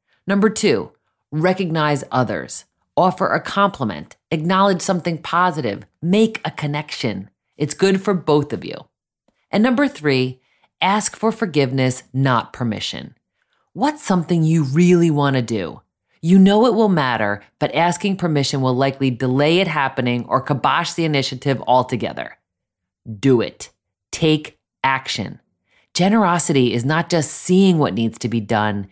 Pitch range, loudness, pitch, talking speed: 130-185 Hz, -18 LUFS, 150 Hz, 135 wpm